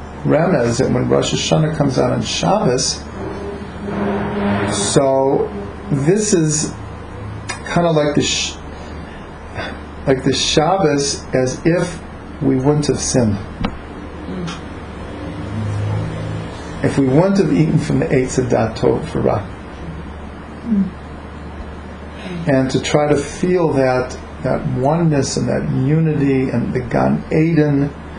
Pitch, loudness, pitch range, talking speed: 110 Hz, -17 LUFS, 85-145 Hz, 115 wpm